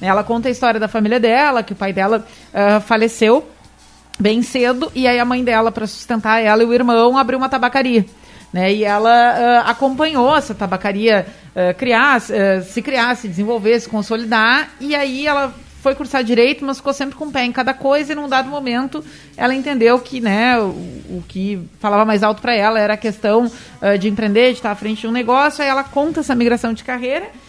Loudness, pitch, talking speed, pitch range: -16 LUFS, 235 Hz, 210 wpm, 215-265 Hz